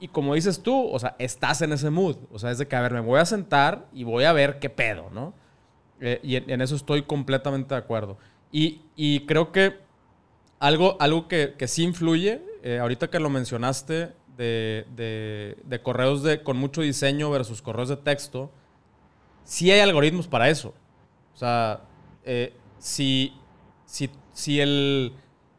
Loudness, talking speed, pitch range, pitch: -24 LUFS, 180 wpm, 125-155 Hz, 140 Hz